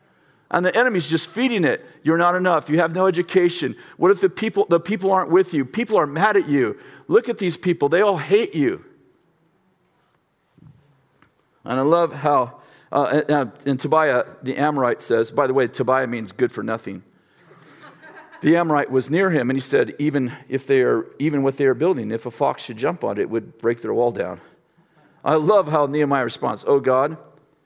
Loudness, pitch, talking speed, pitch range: -20 LUFS, 150 Hz, 195 wpm, 135-180 Hz